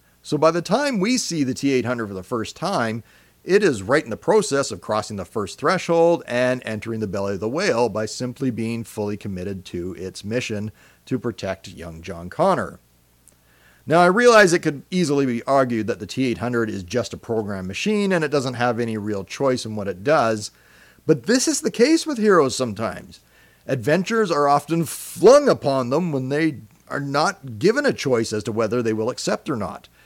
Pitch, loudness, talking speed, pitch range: 120 Hz, -21 LUFS, 200 wpm, 105-145 Hz